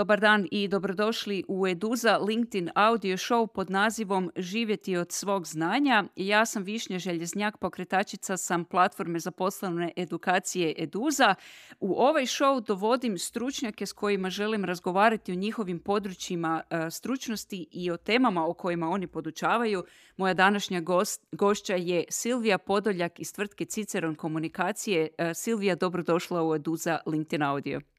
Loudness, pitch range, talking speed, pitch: -28 LUFS, 175-215 Hz, 135 wpm, 190 Hz